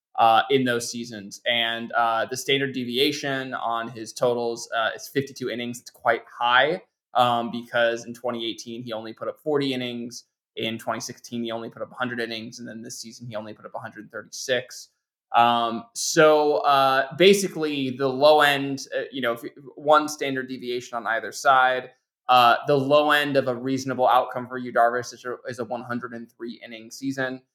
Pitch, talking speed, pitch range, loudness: 125 Hz, 175 wpm, 115-135 Hz, -23 LUFS